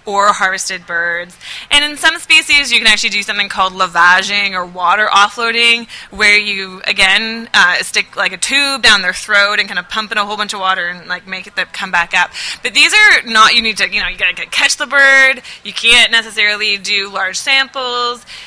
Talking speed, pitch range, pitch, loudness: 215 wpm, 190-240 Hz, 210 Hz, -11 LUFS